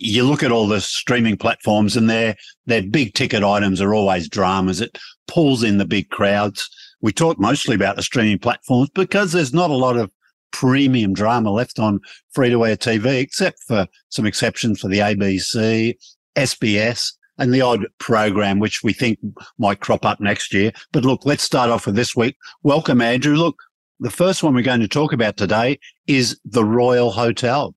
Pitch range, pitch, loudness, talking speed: 105-130 Hz, 115 Hz, -18 LUFS, 190 wpm